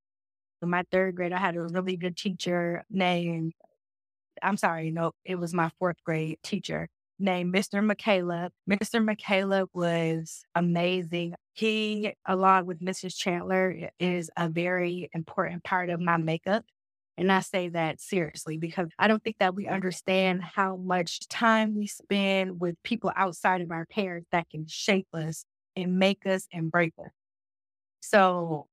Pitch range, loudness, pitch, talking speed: 170-190 Hz, -28 LUFS, 180 Hz, 155 wpm